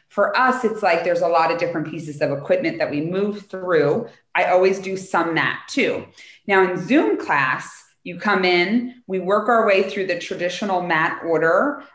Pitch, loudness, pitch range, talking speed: 190 Hz, -20 LUFS, 170-205 Hz, 190 wpm